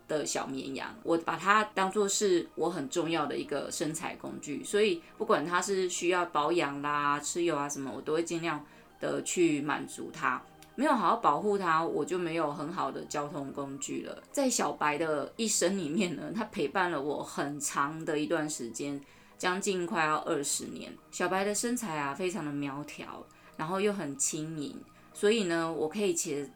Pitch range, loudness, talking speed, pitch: 145-195 Hz, -31 LUFS, 265 characters per minute, 165 Hz